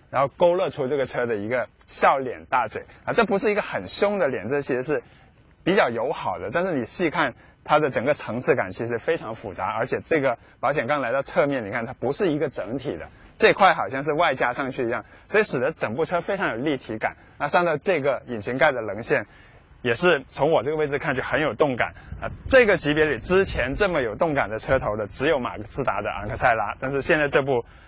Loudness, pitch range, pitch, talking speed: -23 LUFS, 115-180 Hz, 145 Hz, 335 characters per minute